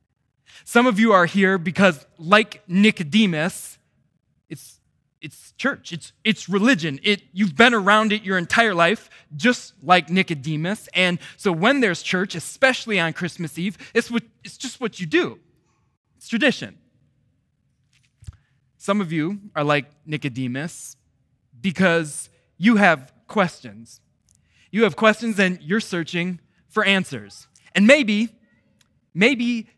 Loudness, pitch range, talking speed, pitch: -20 LUFS, 150-215 Hz, 130 wpm, 185 Hz